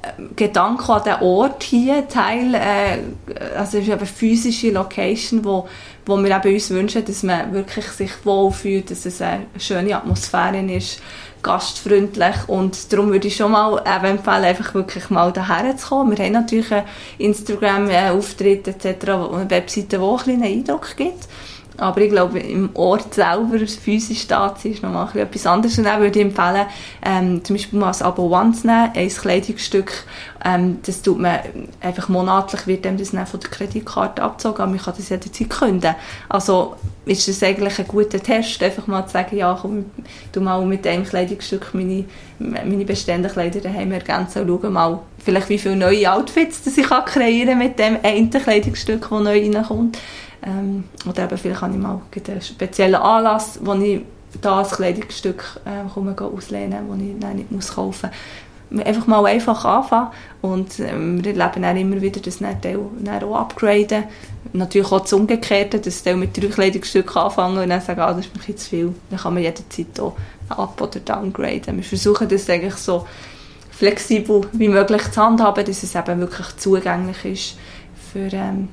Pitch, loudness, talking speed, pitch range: 195 Hz, -19 LUFS, 180 wpm, 185-210 Hz